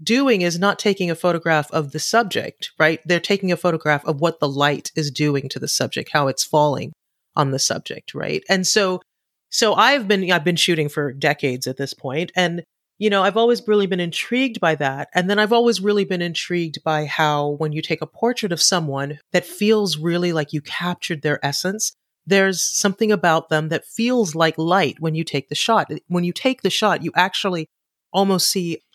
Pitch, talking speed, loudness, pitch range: 175 Hz, 210 wpm, -19 LUFS, 155-195 Hz